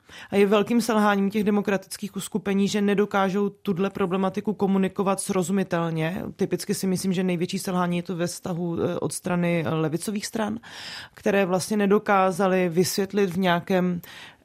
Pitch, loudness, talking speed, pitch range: 195 Hz, -24 LUFS, 135 wpm, 180-205 Hz